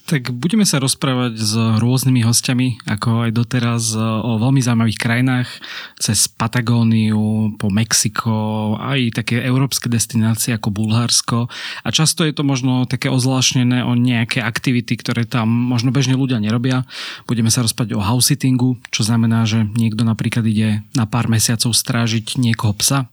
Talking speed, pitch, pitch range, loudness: 150 wpm, 120 Hz, 115-130 Hz, -17 LUFS